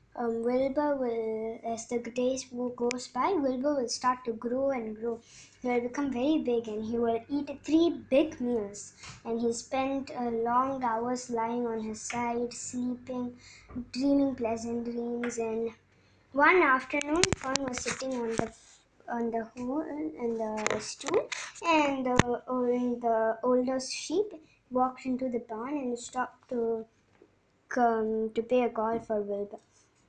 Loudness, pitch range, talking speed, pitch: -30 LUFS, 230-265 Hz, 150 wpm, 245 Hz